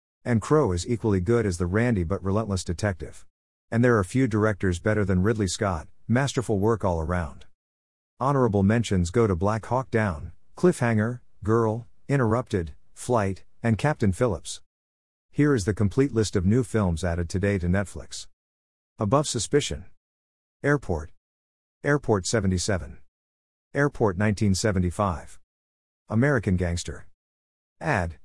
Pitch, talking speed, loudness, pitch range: 100 Hz, 125 wpm, -25 LUFS, 85-115 Hz